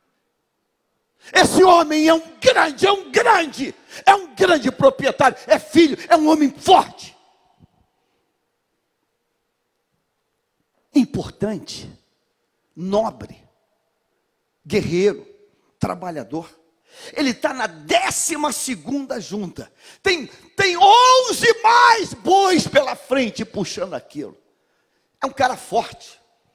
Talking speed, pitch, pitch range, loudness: 95 wpm, 320 Hz, 255-395 Hz, -17 LUFS